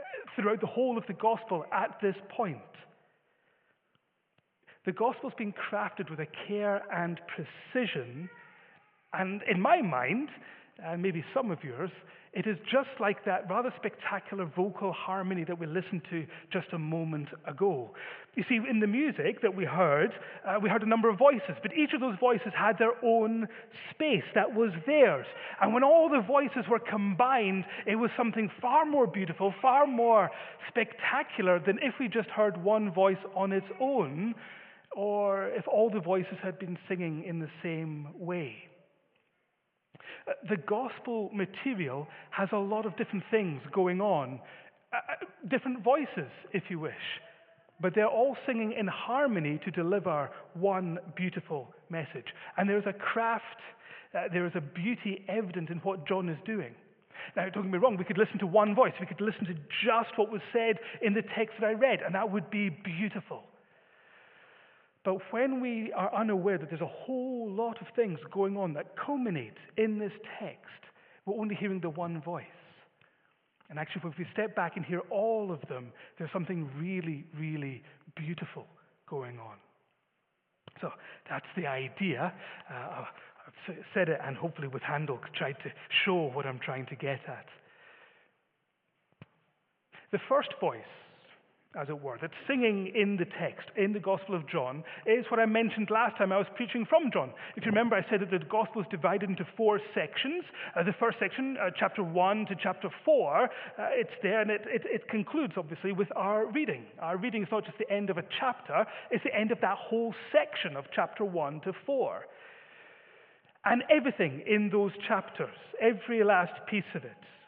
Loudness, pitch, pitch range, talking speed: -31 LUFS, 200 Hz, 175-225 Hz, 175 wpm